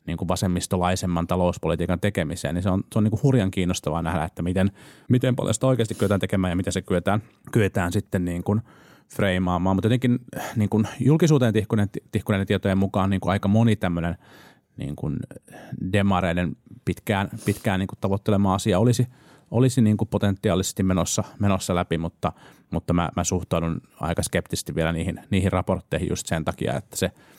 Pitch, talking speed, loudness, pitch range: 95 Hz, 155 wpm, -24 LUFS, 90-110 Hz